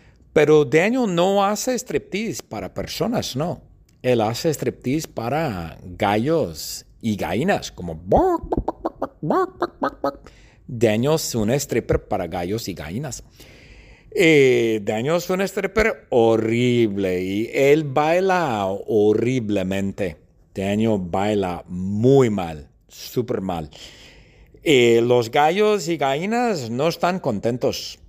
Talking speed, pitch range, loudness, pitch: 105 wpm, 105-165 Hz, -21 LUFS, 120 Hz